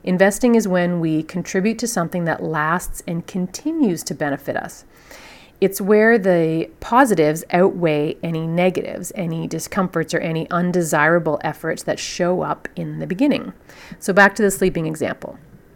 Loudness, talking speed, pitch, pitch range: -19 LUFS, 150 wpm, 175 Hz, 160-195 Hz